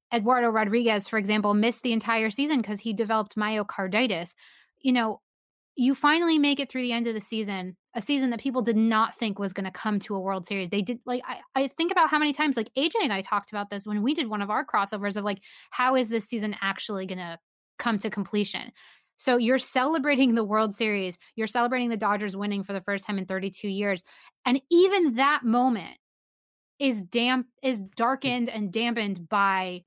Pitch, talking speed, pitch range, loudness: 225 Hz, 210 wpm, 205-255 Hz, -26 LUFS